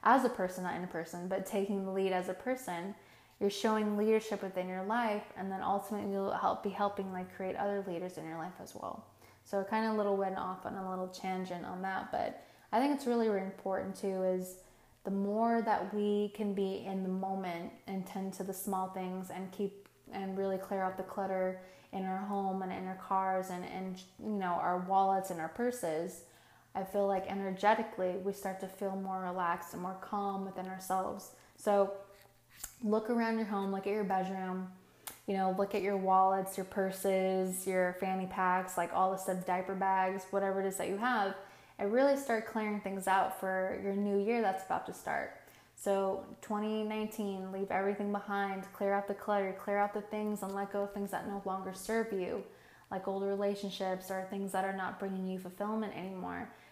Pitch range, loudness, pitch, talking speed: 185-200 Hz, -36 LUFS, 195 Hz, 205 wpm